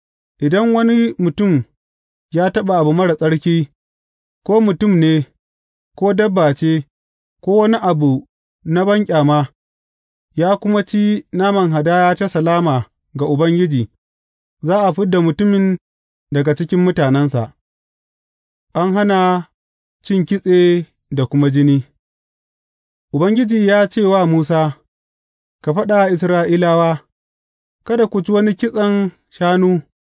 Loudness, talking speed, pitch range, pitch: -15 LUFS, 125 wpm, 135-195 Hz, 165 Hz